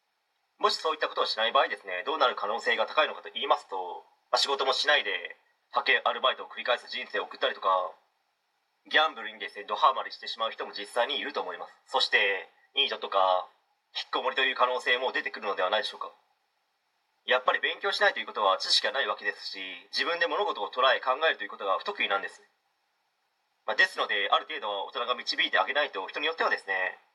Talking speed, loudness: 475 characters per minute, -28 LUFS